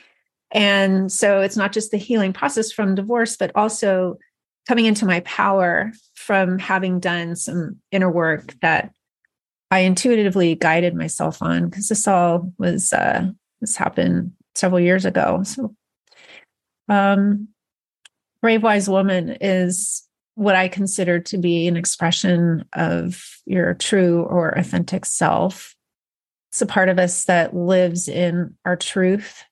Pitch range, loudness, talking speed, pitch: 175-205 Hz, -19 LUFS, 135 wpm, 190 Hz